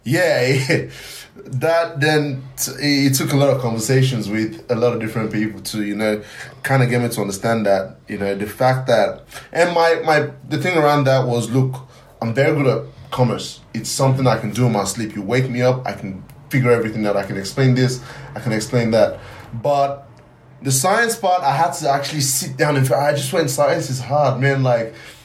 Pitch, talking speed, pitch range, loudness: 130 Hz, 215 wpm, 115-140 Hz, -18 LUFS